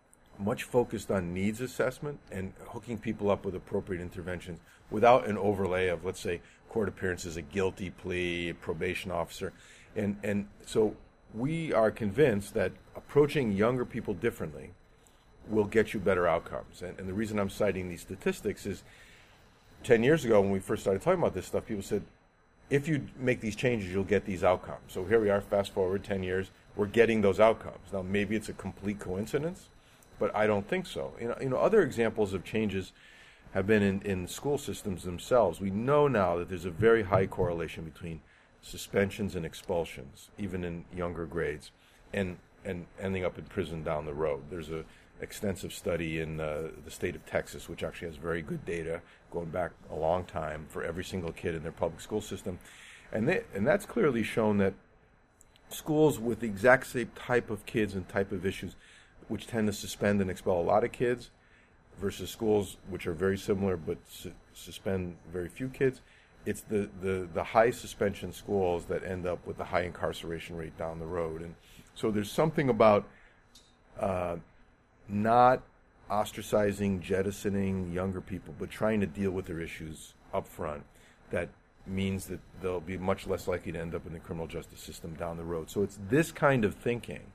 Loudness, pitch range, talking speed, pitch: -31 LUFS, 90-110 Hz, 185 wpm, 95 Hz